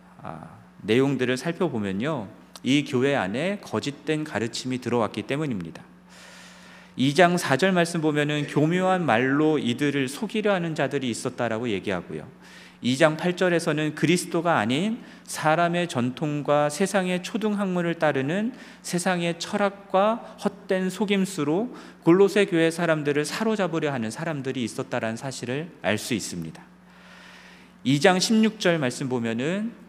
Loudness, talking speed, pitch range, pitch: -24 LUFS, 295 characters per minute, 135-190 Hz, 160 Hz